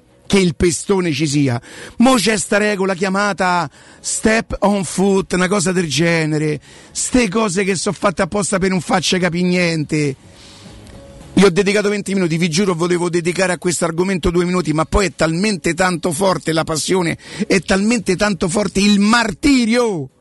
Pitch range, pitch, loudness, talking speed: 165-205 Hz, 185 Hz, -16 LUFS, 165 wpm